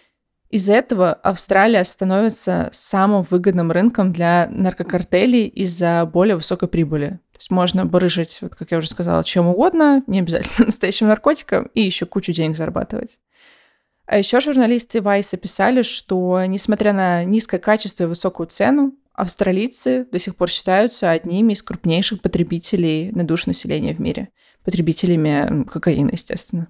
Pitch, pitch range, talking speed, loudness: 185 Hz, 175-215 Hz, 140 wpm, -18 LUFS